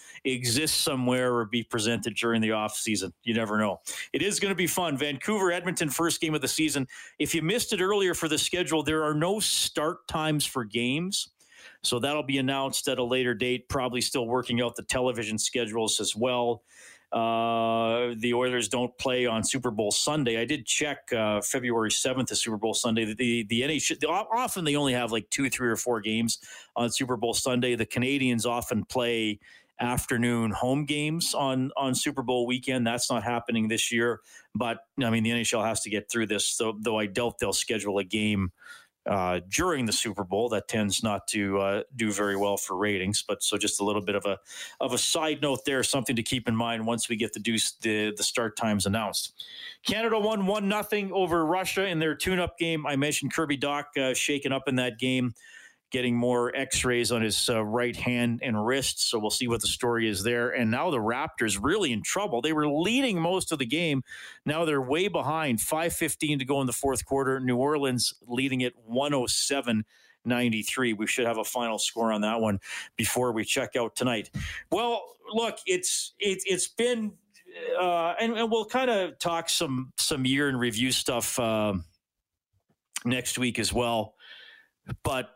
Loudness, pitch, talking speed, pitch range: -27 LUFS, 125 Hz, 200 wpm, 115-150 Hz